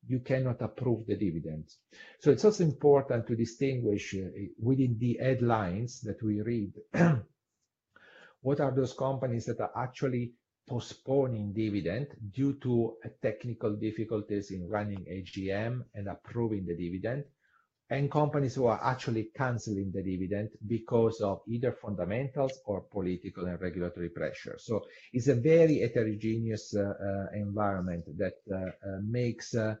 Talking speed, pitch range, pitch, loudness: 135 wpm, 100-130 Hz, 115 Hz, -32 LUFS